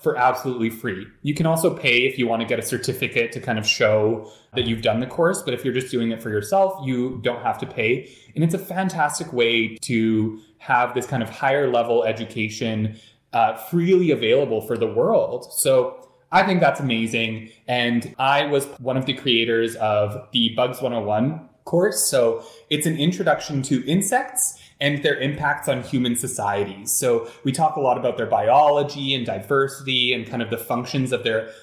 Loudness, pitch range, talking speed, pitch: -21 LUFS, 115-150 Hz, 190 wpm, 130 Hz